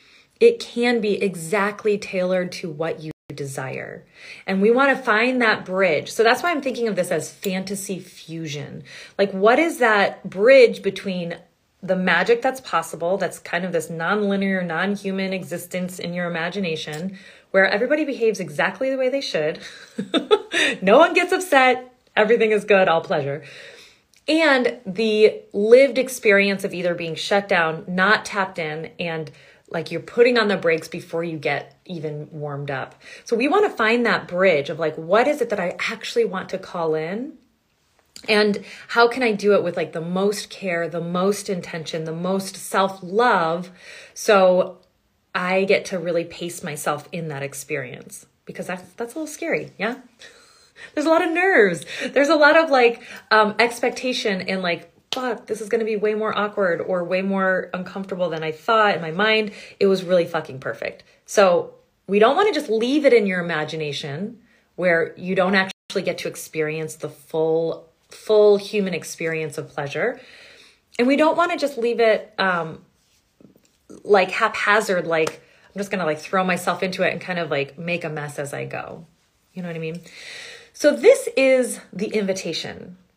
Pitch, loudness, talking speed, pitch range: 195 Hz, -21 LUFS, 180 wpm, 170-235 Hz